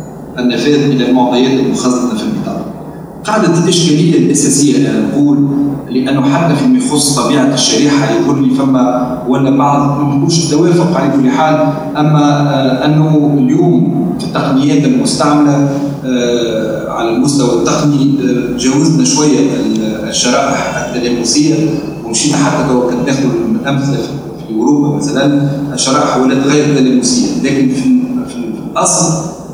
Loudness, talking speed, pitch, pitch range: -11 LUFS, 115 wpm, 145 Hz, 130-155 Hz